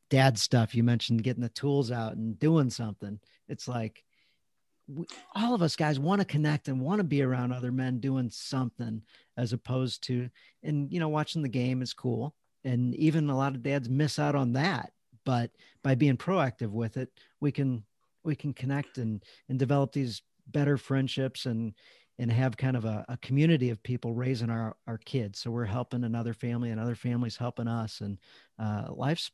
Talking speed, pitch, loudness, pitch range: 195 wpm, 125 Hz, -30 LUFS, 115-140 Hz